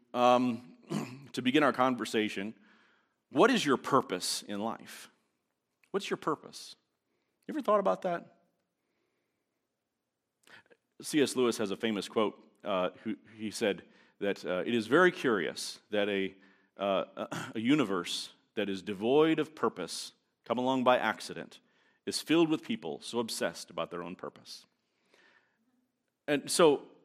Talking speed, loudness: 135 wpm, -31 LUFS